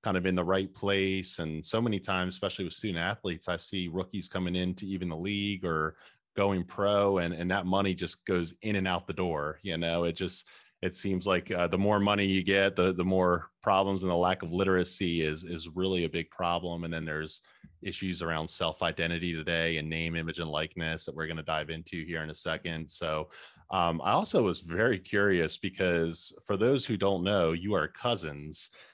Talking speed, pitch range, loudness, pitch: 215 wpm, 85-95 Hz, -31 LUFS, 90 Hz